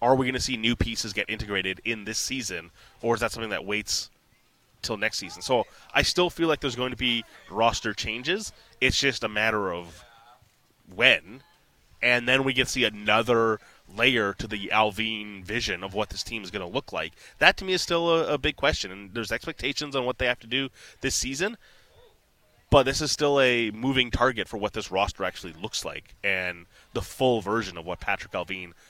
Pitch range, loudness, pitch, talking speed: 105-130 Hz, -26 LUFS, 115 Hz, 210 wpm